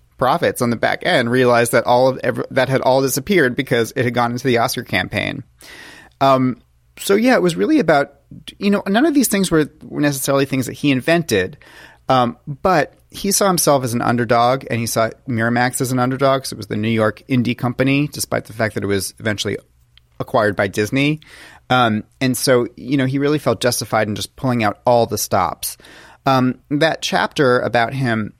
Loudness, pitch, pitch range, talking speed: -17 LUFS, 125 Hz, 115-140 Hz, 200 wpm